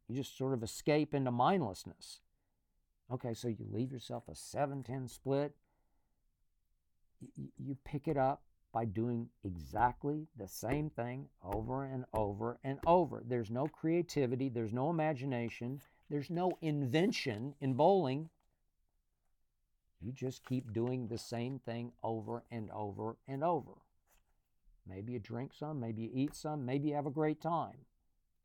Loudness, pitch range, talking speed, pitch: -38 LUFS, 110-145 Hz, 145 wpm, 125 Hz